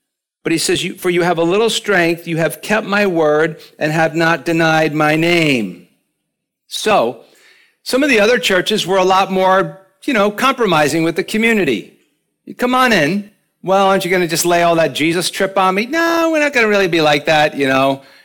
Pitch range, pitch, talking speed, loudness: 165-215 Hz, 190 Hz, 210 wpm, -14 LUFS